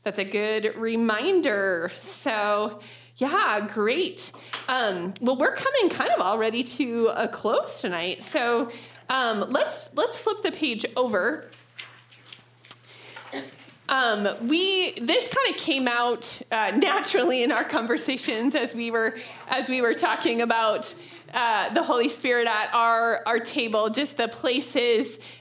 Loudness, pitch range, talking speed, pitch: -24 LUFS, 220-280 Hz, 135 wpm, 235 Hz